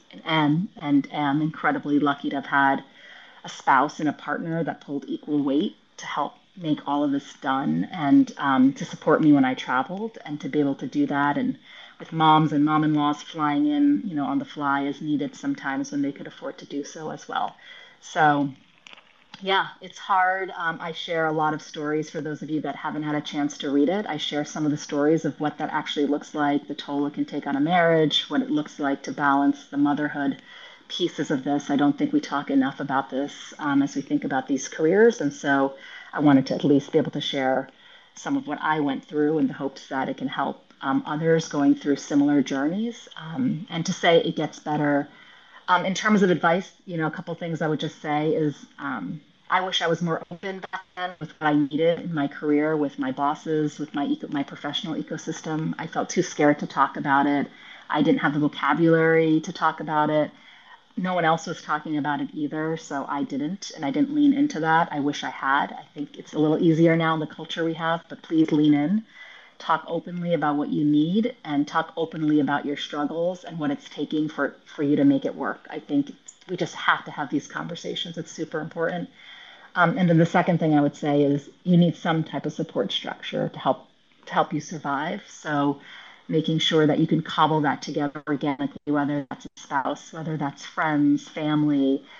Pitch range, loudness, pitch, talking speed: 145-180 Hz, -24 LUFS, 155 Hz, 220 wpm